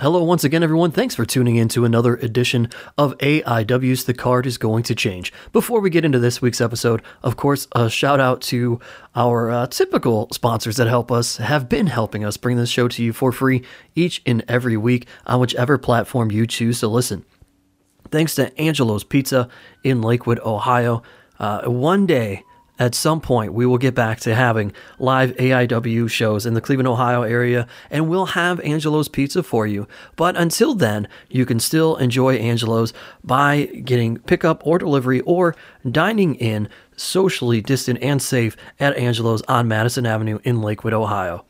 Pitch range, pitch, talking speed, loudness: 115-140 Hz, 125 Hz, 180 wpm, -19 LUFS